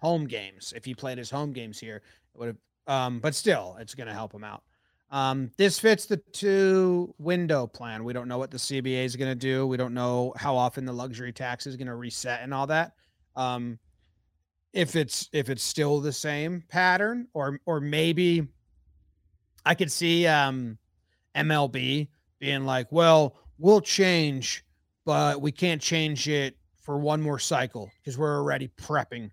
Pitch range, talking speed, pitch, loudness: 120-155 Hz, 180 wpm, 135 Hz, -26 LUFS